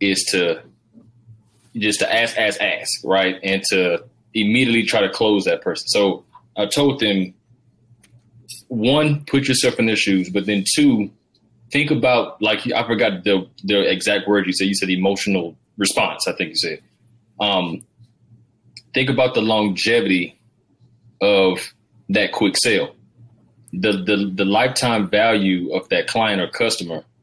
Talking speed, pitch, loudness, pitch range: 150 wpm, 115 Hz, -18 LUFS, 100-120 Hz